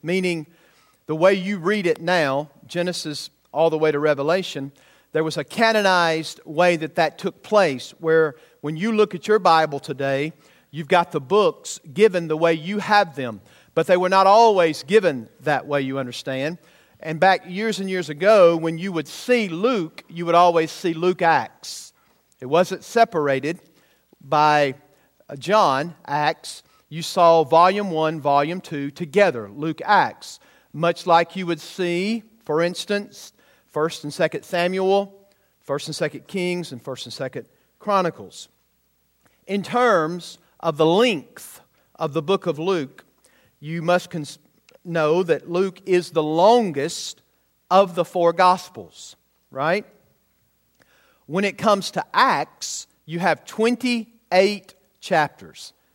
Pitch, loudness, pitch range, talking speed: 170 Hz, -21 LUFS, 155-190 Hz, 145 wpm